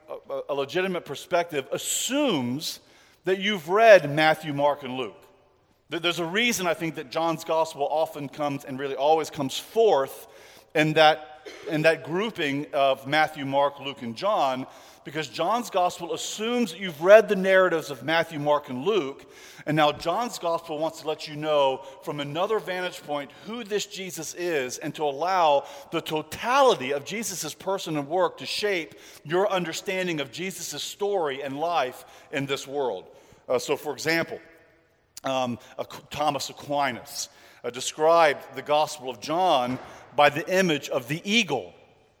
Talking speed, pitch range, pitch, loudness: 155 wpm, 140-185 Hz, 155 Hz, -25 LUFS